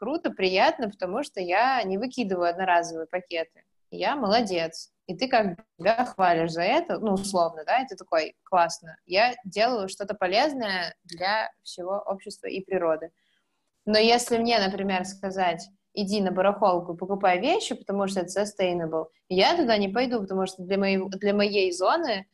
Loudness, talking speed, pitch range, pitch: -26 LUFS, 150 wpm, 180-220 Hz, 195 Hz